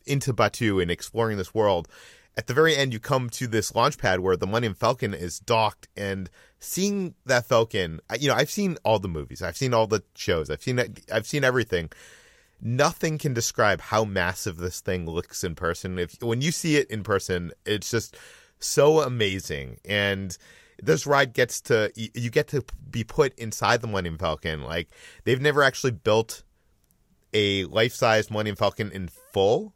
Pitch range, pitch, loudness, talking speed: 95-125 Hz, 110 Hz, -25 LUFS, 180 wpm